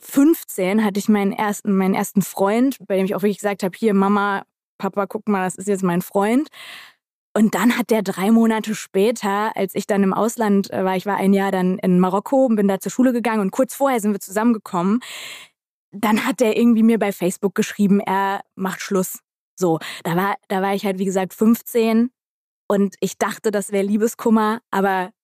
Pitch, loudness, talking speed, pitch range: 200 Hz, -19 LUFS, 200 wpm, 195-225 Hz